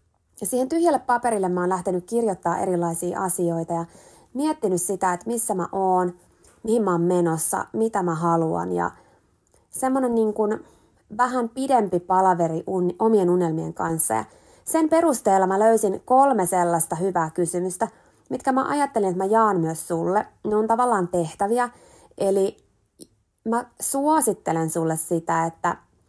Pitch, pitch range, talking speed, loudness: 190 Hz, 170-230 Hz, 140 wpm, -22 LUFS